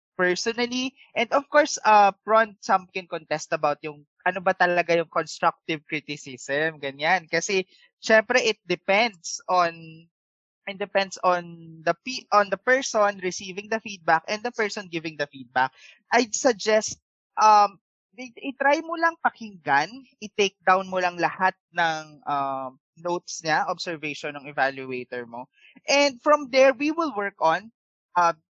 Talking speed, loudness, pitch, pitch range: 150 wpm, -24 LUFS, 185 Hz, 160-225 Hz